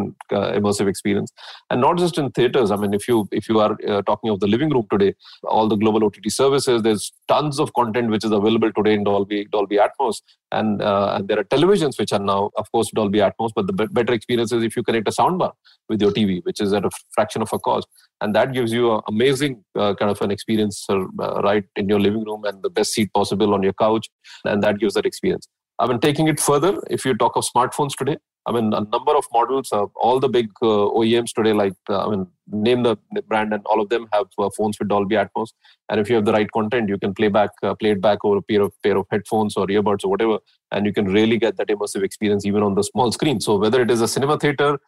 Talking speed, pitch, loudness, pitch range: 255 wpm, 110 Hz, -20 LUFS, 105-120 Hz